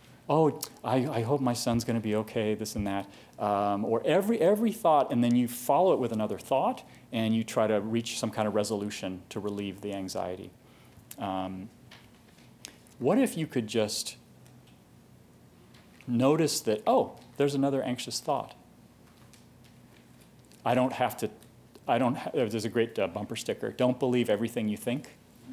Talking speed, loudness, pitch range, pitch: 160 wpm, -29 LUFS, 105-125 Hz, 115 Hz